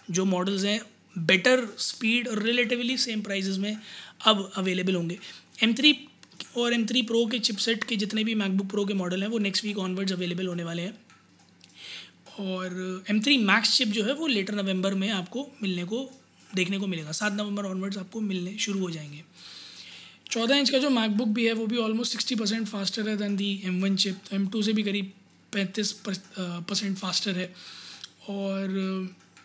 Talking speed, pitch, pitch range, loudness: 175 wpm, 200 Hz, 190-225 Hz, -27 LUFS